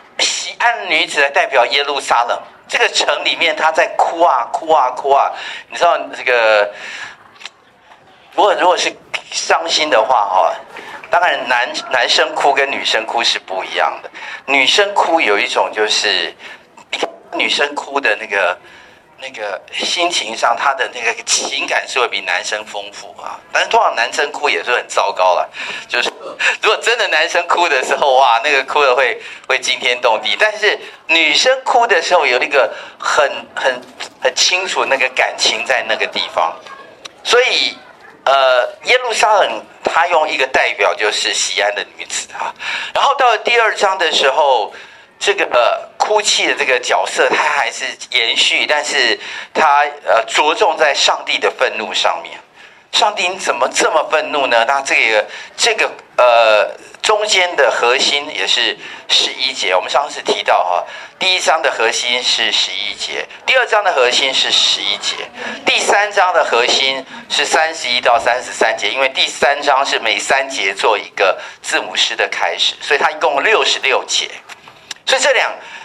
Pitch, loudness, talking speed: 165 Hz, -14 LUFS, 240 characters per minute